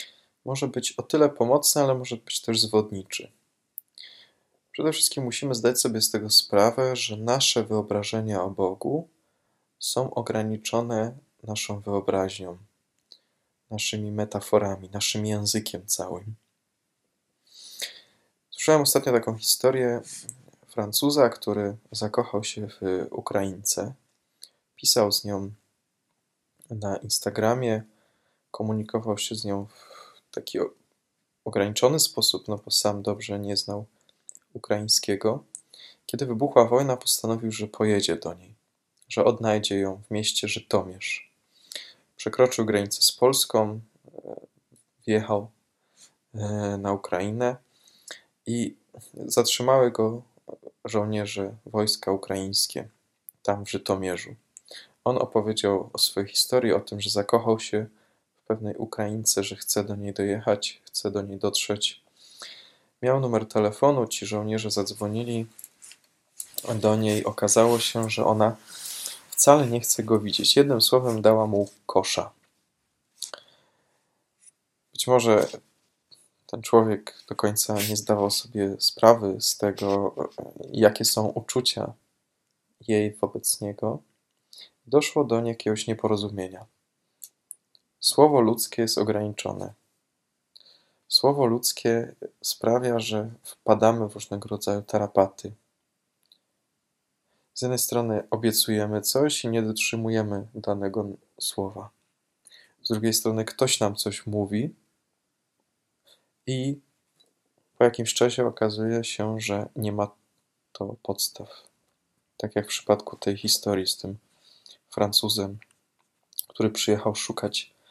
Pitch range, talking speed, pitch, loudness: 105-115 Hz, 110 wpm, 110 Hz, -25 LUFS